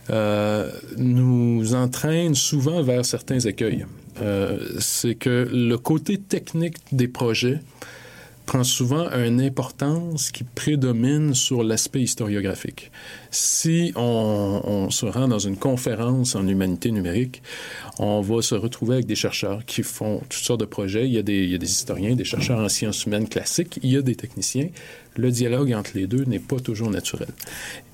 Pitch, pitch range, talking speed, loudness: 125 Hz, 105-135 Hz, 165 wpm, -23 LUFS